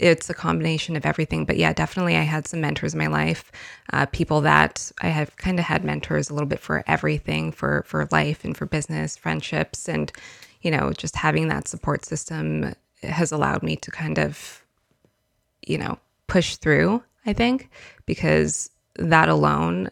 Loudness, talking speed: -23 LUFS, 180 wpm